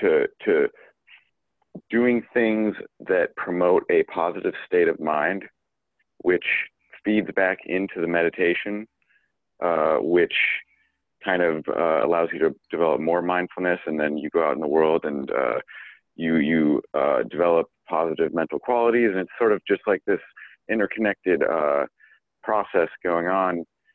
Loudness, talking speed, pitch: -23 LUFS, 145 wpm, 105 Hz